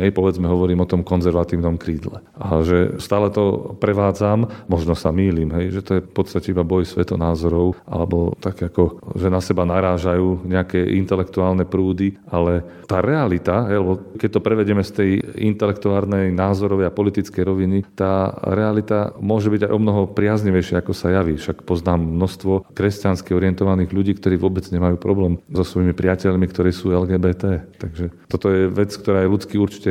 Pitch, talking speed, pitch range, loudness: 95 Hz, 165 wpm, 90-100 Hz, -19 LUFS